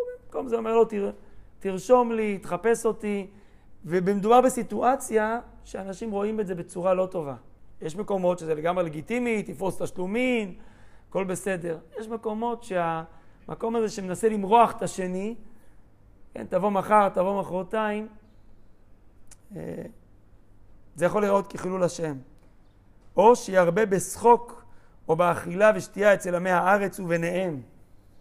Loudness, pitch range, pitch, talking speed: -25 LUFS, 155-215 Hz, 185 Hz, 115 wpm